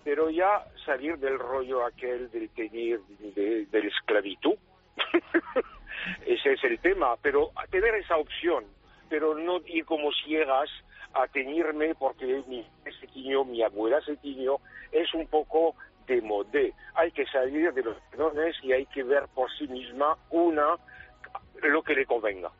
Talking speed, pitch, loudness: 155 wpm, 155 Hz, -28 LUFS